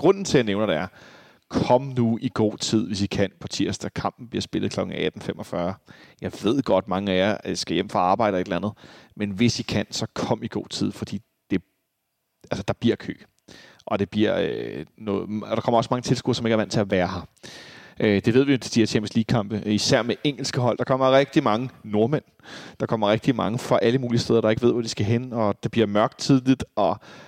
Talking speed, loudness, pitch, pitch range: 240 wpm, -24 LUFS, 115 Hz, 105-125 Hz